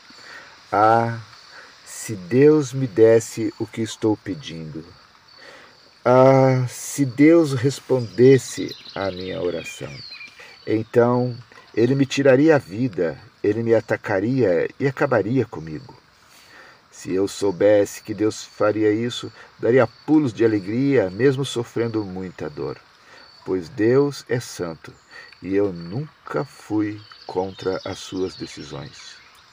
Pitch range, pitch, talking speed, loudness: 100-130 Hz, 115 Hz, 110 wpm, -20 LUFS